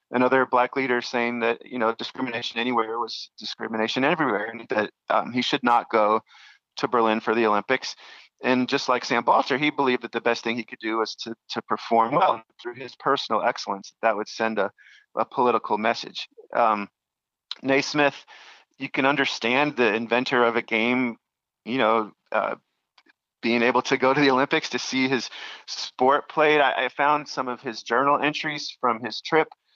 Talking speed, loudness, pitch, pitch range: 185 wpm, -24 LUFS, 125 Hz, 115-135 Hz